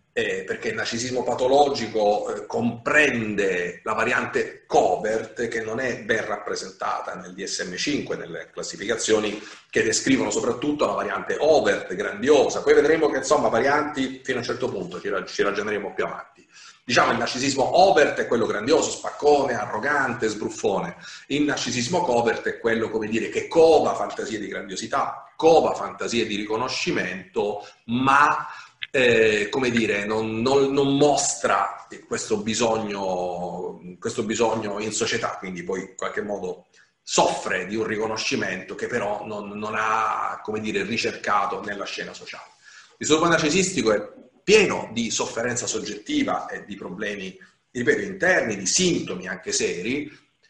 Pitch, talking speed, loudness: 135 Hz, 145 wpm, -23 LUFS